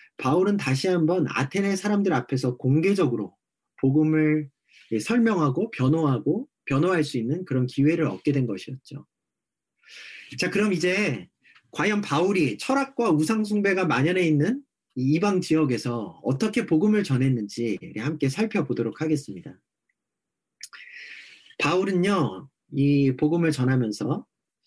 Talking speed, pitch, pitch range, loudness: 275 characters per minute, 155 Hz, 135-195 Hz, -24 LUFS